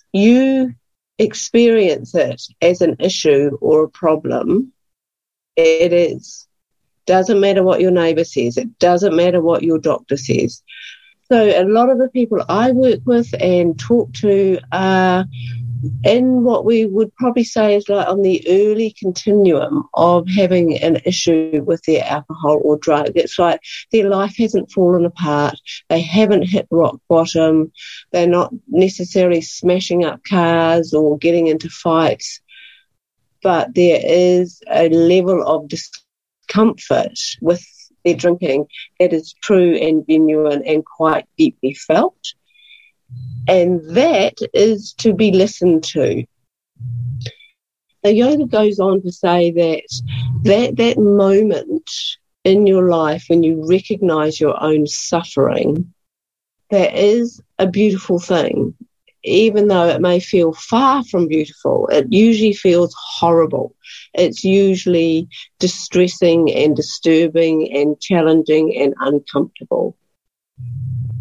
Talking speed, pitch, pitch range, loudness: 130 wpm, 180 Hz, 160-210 Hz, -15 LUFS